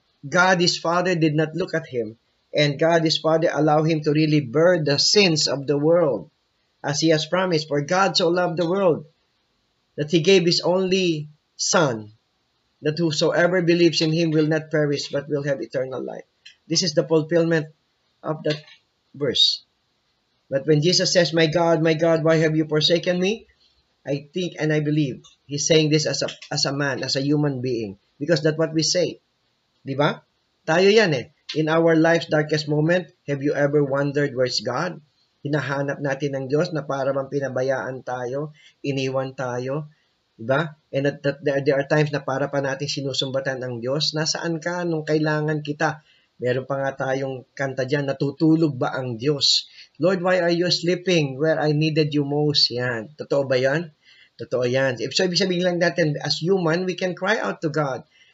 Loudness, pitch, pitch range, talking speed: -21 LUFS, 155 Hz, 140-170 Hz, 180 wpm